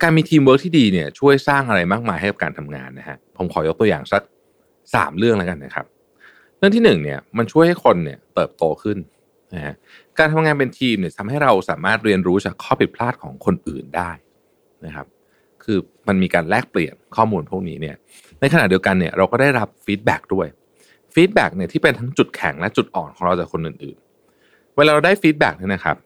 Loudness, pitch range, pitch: -18 LUFS, 95-155 Hz, 120 Hz